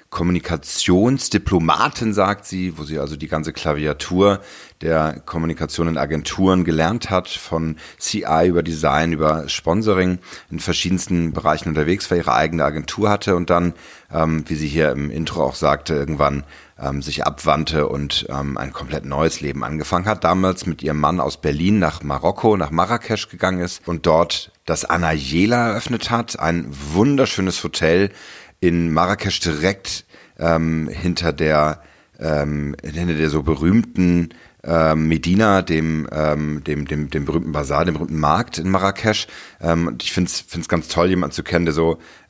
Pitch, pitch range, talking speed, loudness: 80 Hz, 75-90 Hz, 155 wpm, -19 LUFS